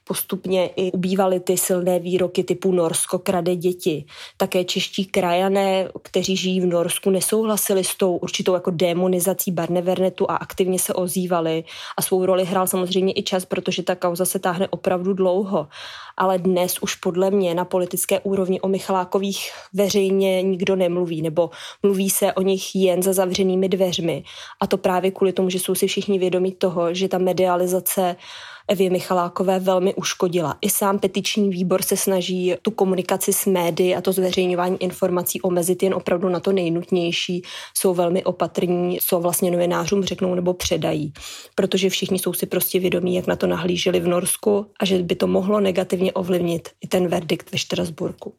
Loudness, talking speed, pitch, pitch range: -21 LUFS, 165 wpm, 185 Hz, 180-195 Hz